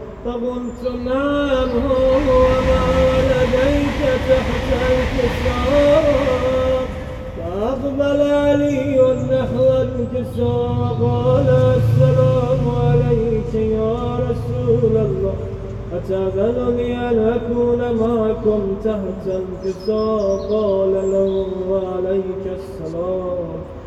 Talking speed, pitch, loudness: 70 wpm, 195 Hz, -18 LUFS